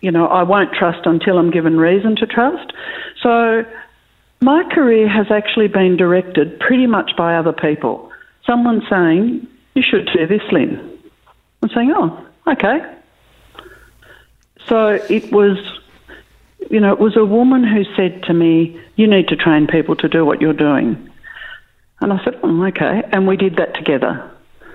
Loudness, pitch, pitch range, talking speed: -14 LUFS, 200 Hz, 170-235 Hz, 160 wpm